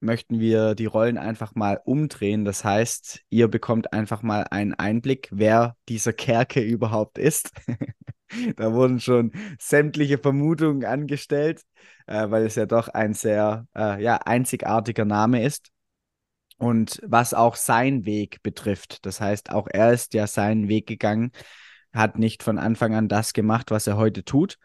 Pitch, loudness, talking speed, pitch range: 115 Hz, -23 LUFS, 155 wpm, 110-125 Hz